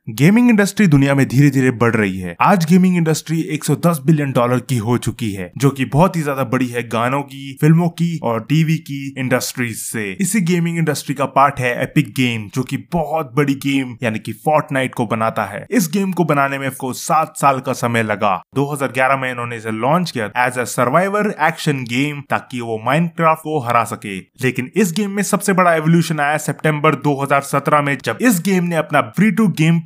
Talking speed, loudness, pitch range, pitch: 200 wpm, -17 LUFS, 125-160 Hz, 140 Hz